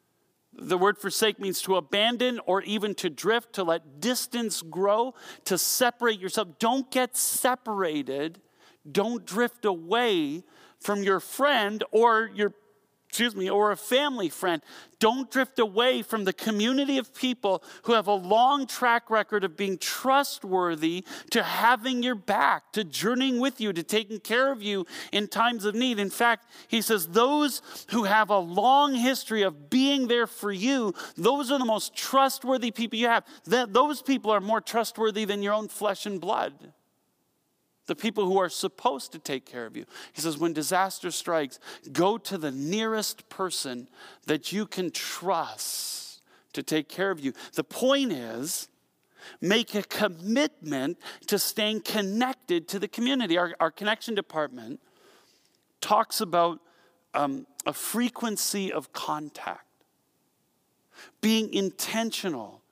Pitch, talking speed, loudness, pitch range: 215 Hz, 150 wpm, -27 LUFS, 190-245 Hz